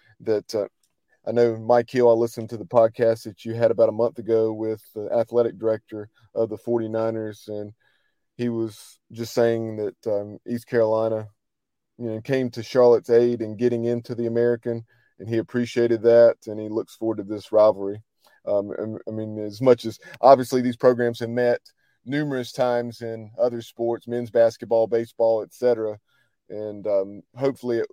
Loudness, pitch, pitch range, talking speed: -23 LUFS, 115 Hz, 110-120 Hz, 175 wpm